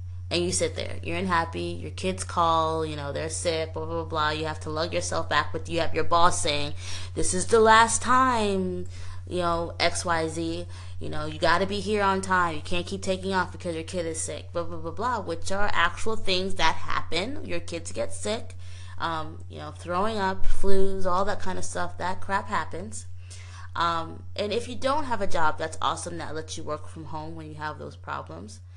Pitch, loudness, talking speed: 90 Hz, -27 LUFS, 220 wpm